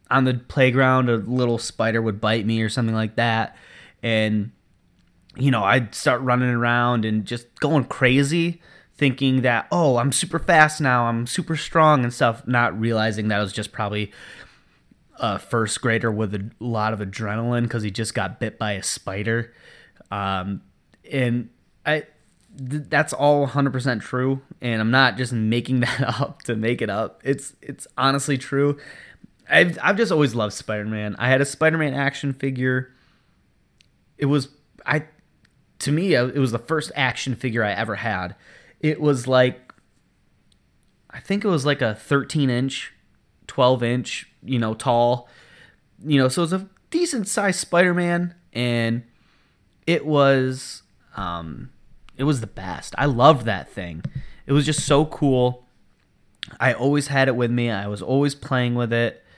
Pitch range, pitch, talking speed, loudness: 115-145 Hz, 125 Hz, 160 wpm, -21 LUFS